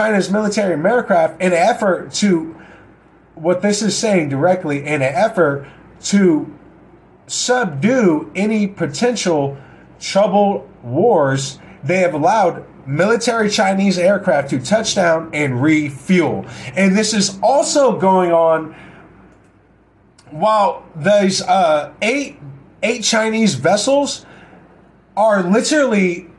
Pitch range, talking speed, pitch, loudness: 160-215 Hz, 105 wpm, 185 Hz, -16 LUFS